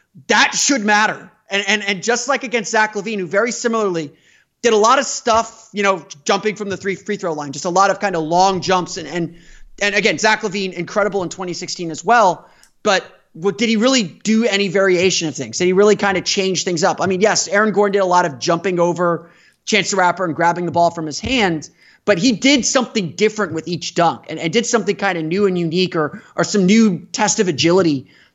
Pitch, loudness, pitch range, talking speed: 195 Hz, -17 LUFS, 175-215 Hz, 235 wpm